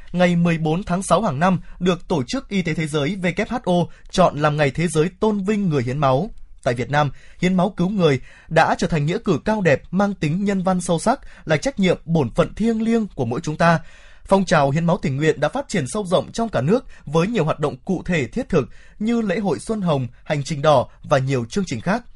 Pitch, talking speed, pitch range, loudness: 175 Hz, 245 wpm, 155-200 Hz, -20 LUFS